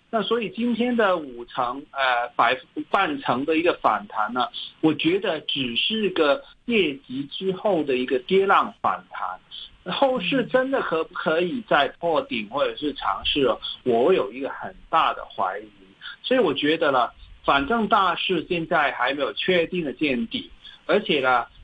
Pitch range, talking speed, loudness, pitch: 145-235 Hz, 235 characters per minute, -23 LUFS, 190 Hz